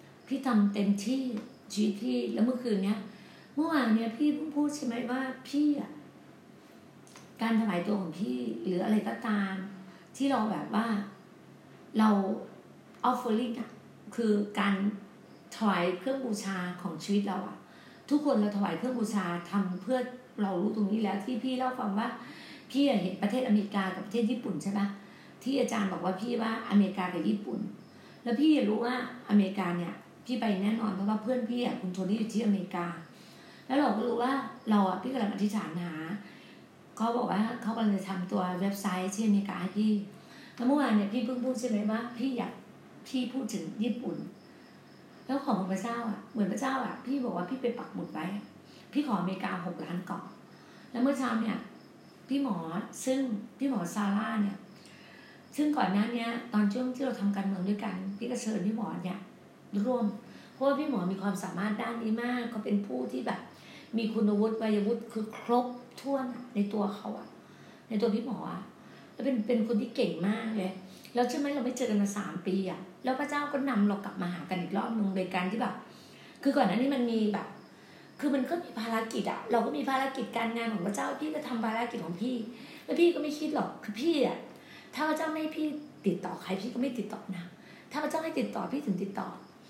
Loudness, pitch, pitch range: -32 LUFS, 220 Hz, 200-250 Hz